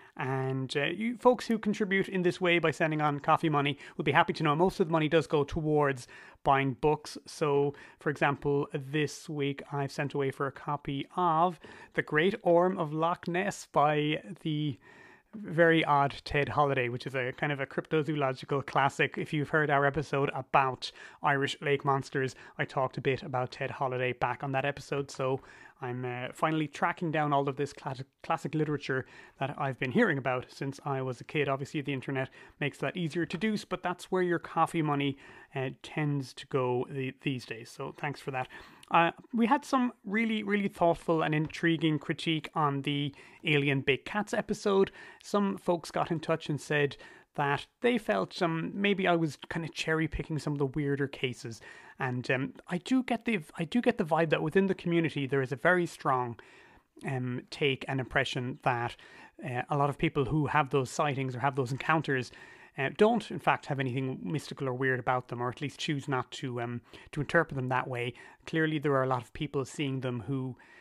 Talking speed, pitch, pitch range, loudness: 200 wpm, 145 Hz, 135-165 Hz, -31 LUFS